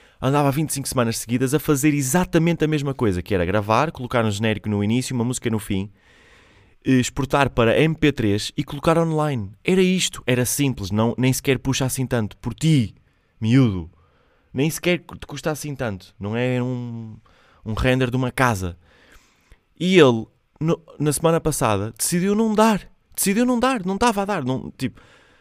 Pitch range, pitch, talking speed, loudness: 110-155 Hz, 130 Hz, 170 wpm, -21 LUFS